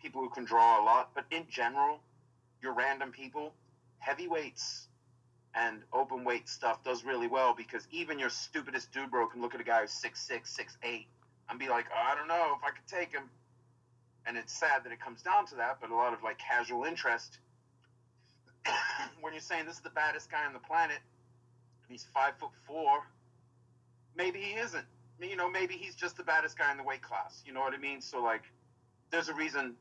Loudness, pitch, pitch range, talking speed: -34 LUFS, 130 Hz, 120-160 Hz, 210 wpm